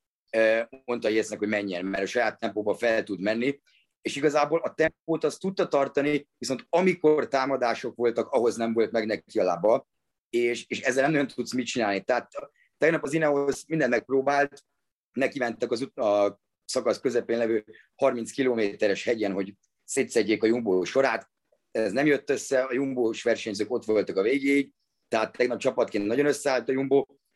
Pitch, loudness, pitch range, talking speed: 125 Hz, -26 LUFS, 110-140 Hz, 170 wpm